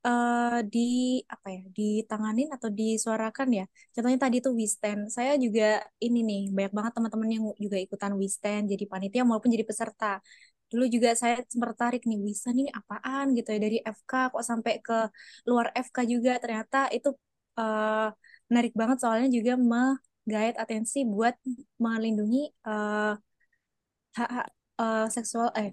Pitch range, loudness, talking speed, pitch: 215-245 Hz, -28 LUFS, 150 wpm, 230 Hz